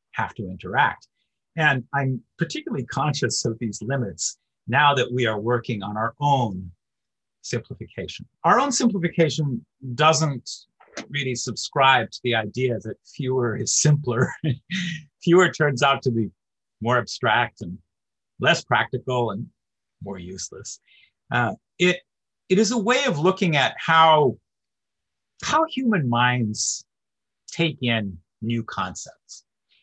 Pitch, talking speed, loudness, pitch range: 130 Hz, 125 wpm, -22 LUFS, 115-160 Hz